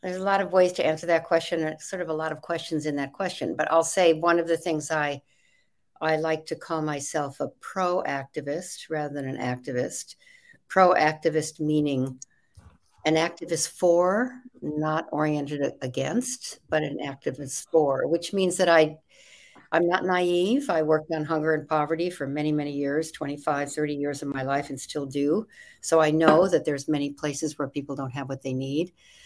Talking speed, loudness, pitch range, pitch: 185 wpm, -26 LUFS, 145-170 Hz, 155 Hz